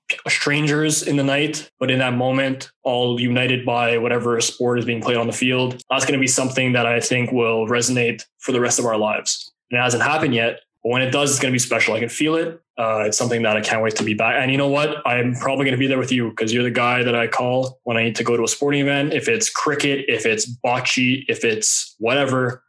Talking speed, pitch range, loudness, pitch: 265 wpm, 120-135 Hz, -19 LUFS, 125 Hz